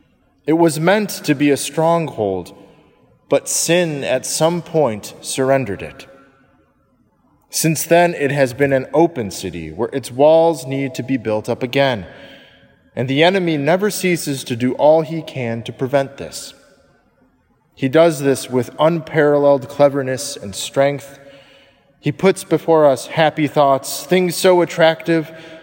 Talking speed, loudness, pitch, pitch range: 145 wpm, -17 LUFS, 140 Hz, 135-160 Hz